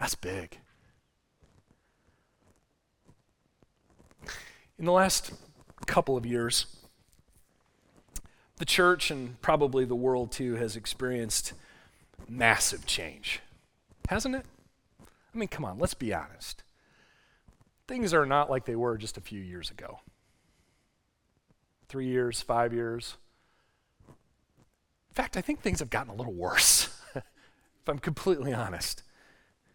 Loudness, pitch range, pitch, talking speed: -29 LUFS, 115-150 Hz, 125 Hz, 115 wpm